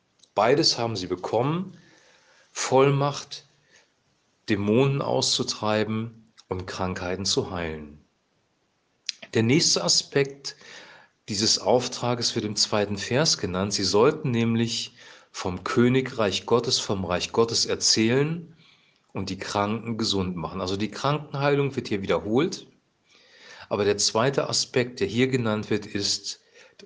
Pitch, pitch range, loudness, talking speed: 115 Hz, 100-135 Hz, -24 LUFS, 115 wpm